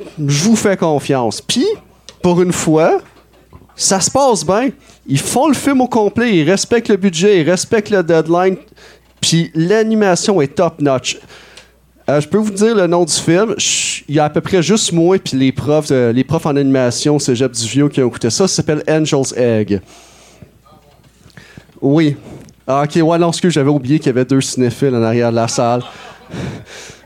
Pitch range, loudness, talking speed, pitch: 135-190 Hz, -14 LUFS, 185 wpm, 160 Hz